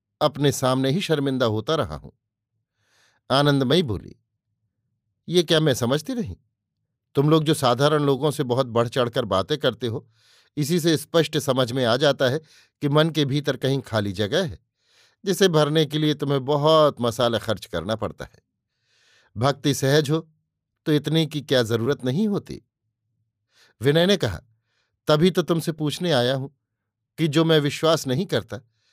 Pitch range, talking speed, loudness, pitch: 115-155 Hz, 160 wpm, -22 LUFS, 135 Hz